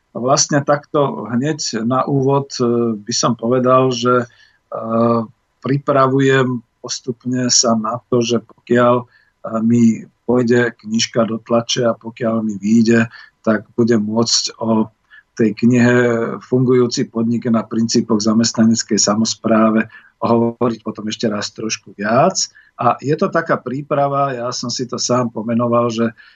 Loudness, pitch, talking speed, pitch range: -16 LUFS, 120 Hz, 125 wpm, 115-125 Hz